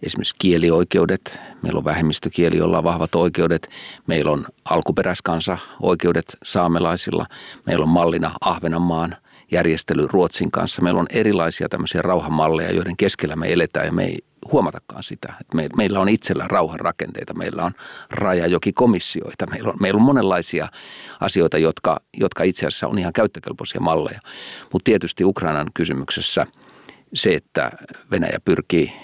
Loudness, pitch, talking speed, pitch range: -20 LUFS, 85 Hz, 125 wpm, 80-90 Hz